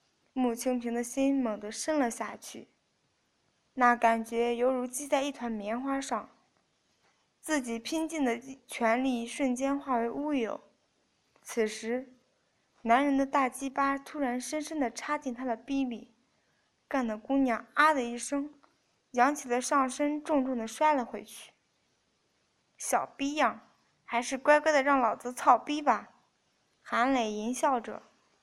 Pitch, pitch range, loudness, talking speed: 255 Hz, 235-280 Hz, -30 LUFS, 200 characters per minute